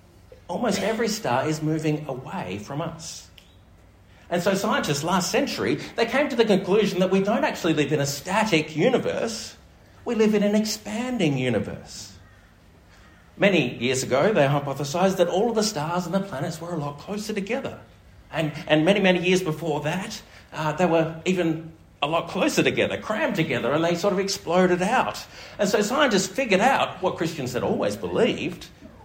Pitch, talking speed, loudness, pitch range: 170 Hz, 175 wpm, -24 LUFS, 140-200 Hz